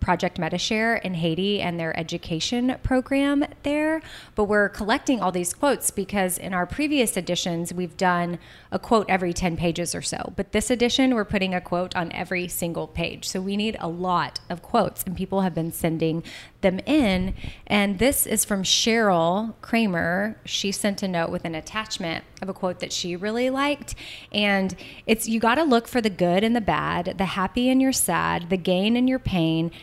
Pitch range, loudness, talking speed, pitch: 175-225 Hz, -24 LUFS, 190 wpm, 190 Hz